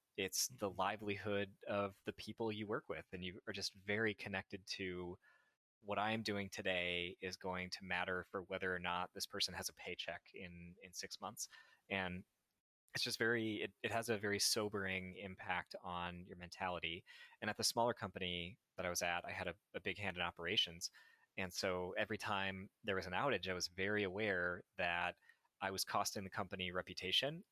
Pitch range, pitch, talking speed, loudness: 90-105 Hz, 95 Hz, 190 wpm, -42 LUFS